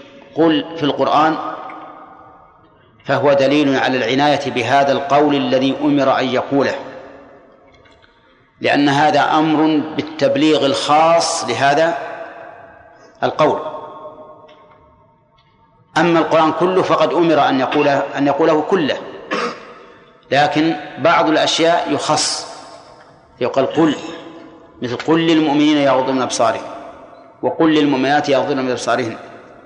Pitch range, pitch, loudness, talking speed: 140-160 Hz, 155 Hz, -15 LUFS, 90 wpm